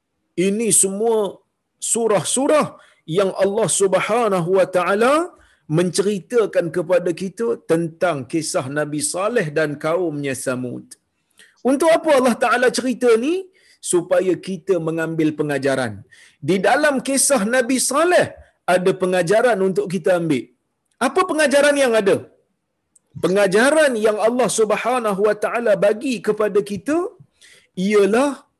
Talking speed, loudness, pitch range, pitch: 110 wpm, -18 LUFS, 180-255 Hz, 205 Hz